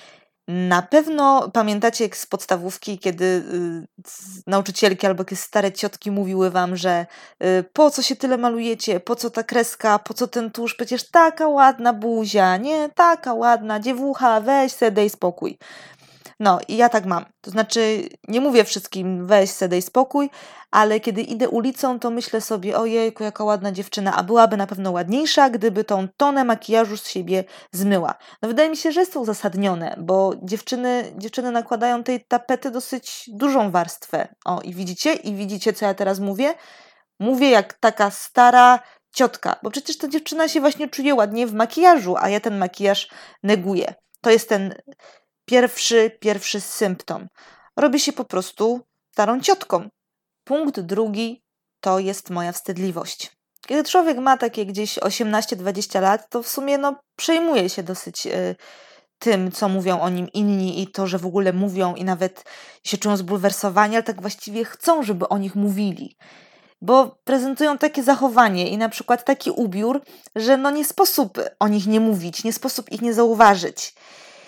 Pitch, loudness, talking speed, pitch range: 220 Hz, -20 LUFS, 165 wpm, 195-255 Hz